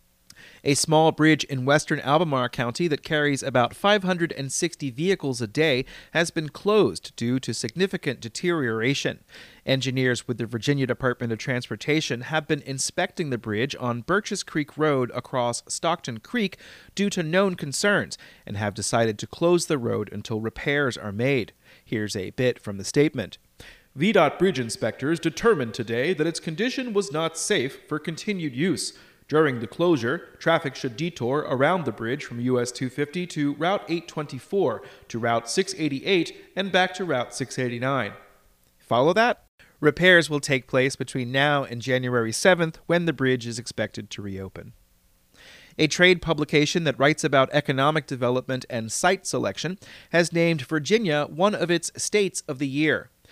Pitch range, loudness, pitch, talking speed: 125-170 Hz, -24 LUFS, 145 Hz, 155 wpm